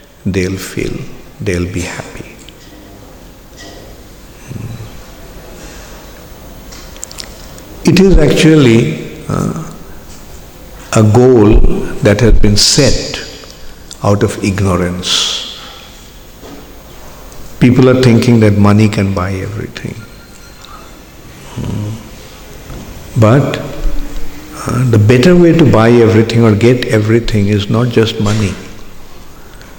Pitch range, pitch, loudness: 100-120 Hz, 110 Hz, -10 LUFS